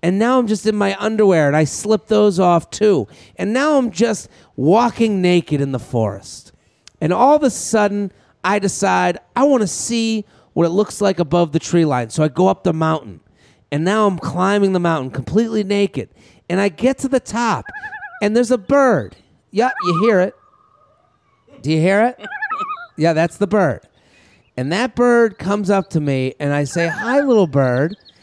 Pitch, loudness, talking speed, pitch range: 195 Hz, -17 LUFS, 190 wpm, 160-225 Hz